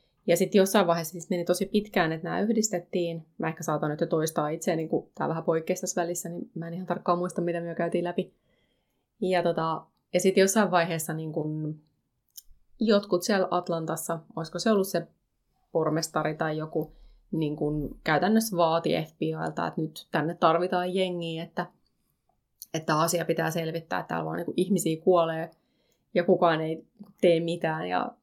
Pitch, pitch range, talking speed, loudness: 170 Hz, 160-180 Hz, 170 wpm, -28 LUFS